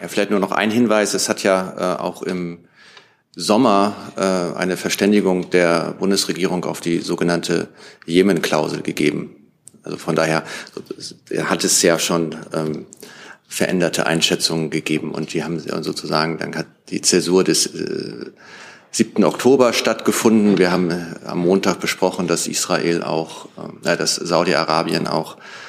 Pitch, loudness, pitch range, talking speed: 85 Hz, -18 LUFS, 80-95 Hz, 135 wpm